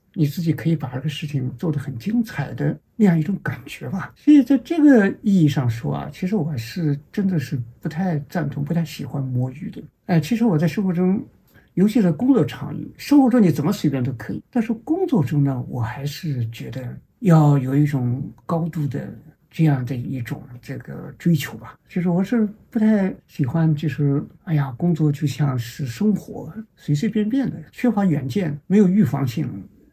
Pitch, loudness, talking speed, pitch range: 160 Hz, -21 LUFS, 280 characters per minute, 140-200 Hz